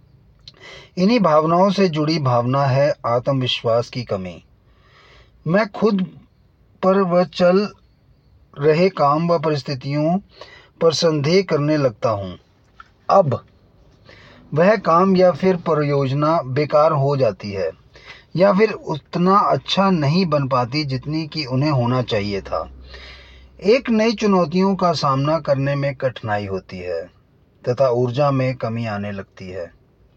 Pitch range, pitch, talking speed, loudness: 120-175 Hz, 145 Hz, 125 wpm, -18 LUFS